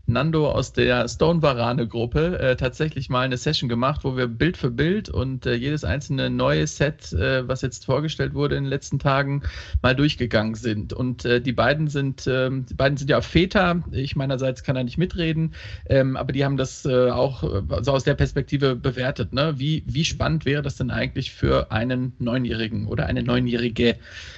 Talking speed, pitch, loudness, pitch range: 190 wpm, 130 Hz, -23 LUFS, 120-145 Hz